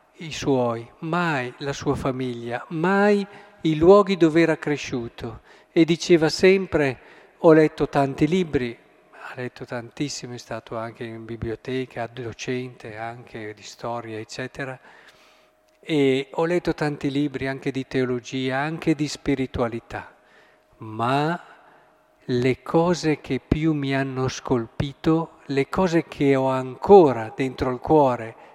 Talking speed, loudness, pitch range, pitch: 125 wpm, -22 LUFS, 125-160 Hz, 135 Hz